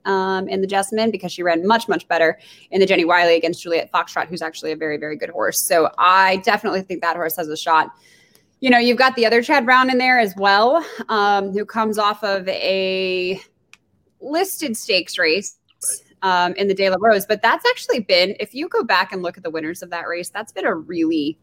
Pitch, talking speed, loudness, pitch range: 195 Hz, 225 wpm, -18 LUFS, 175-230 Hz